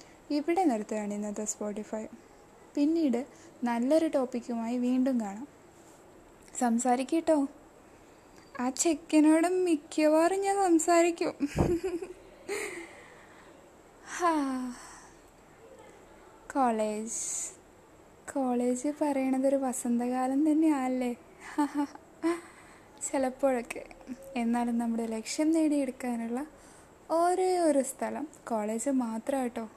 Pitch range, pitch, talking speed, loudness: 245-320 Hz, 275 Hz, 60 wpm, -30 LUFS